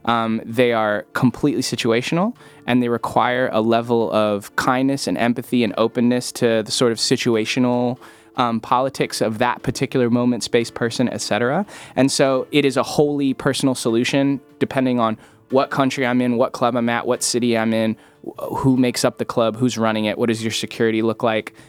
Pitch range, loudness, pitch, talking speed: 115-130 Hz, -19 LUFS, 120 Hz, 185 wpm